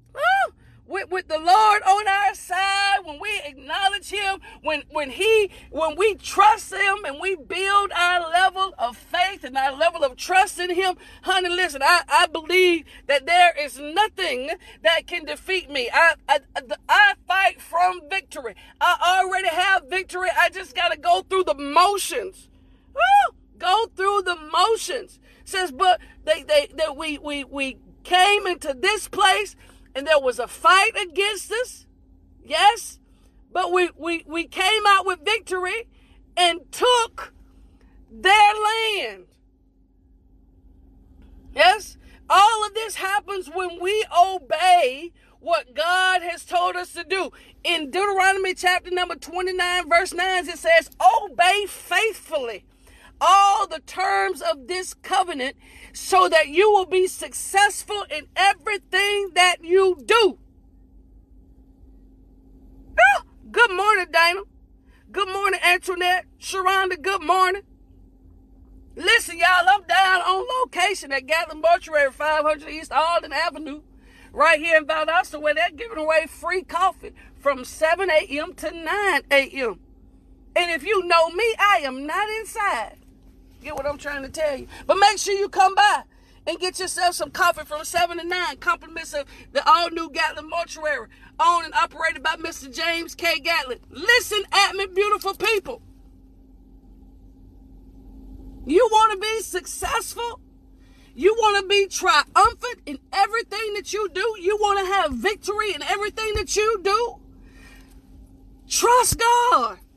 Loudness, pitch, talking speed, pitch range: -20 LUFS, 360 Hz, 140 wpm, 315-395 Hz